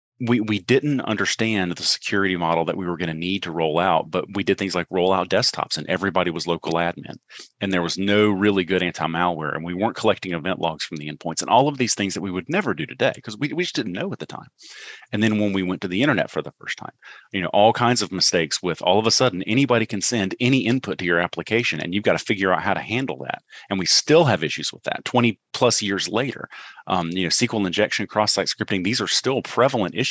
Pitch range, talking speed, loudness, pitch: 90-110 Hz, 255 wpm, -21 LUFS, 95 Hz